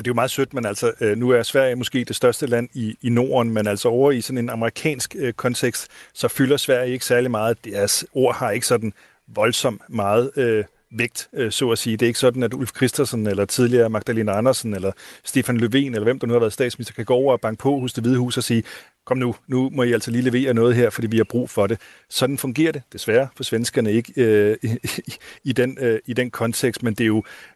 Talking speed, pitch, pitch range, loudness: 250 wpm, 120 Hz, 115-130 Hz, -21 LUFS